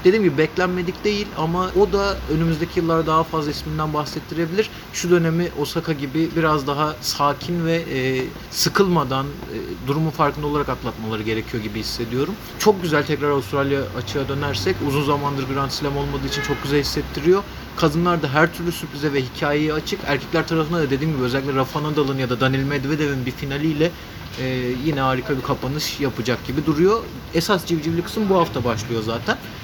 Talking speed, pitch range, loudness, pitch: 160 wpm, 135-165 Hz, -21 LUFS, 150 Hz